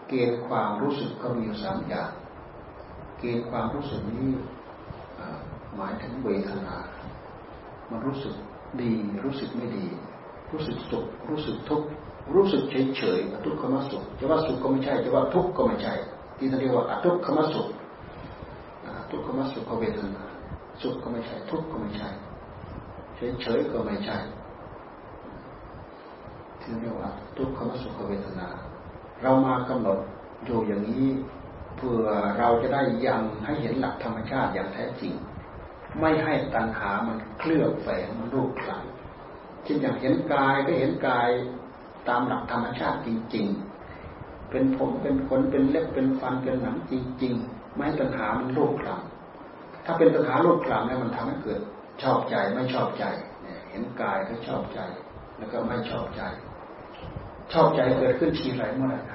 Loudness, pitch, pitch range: -27 LUFS, 120 Hz, 105-130 Hz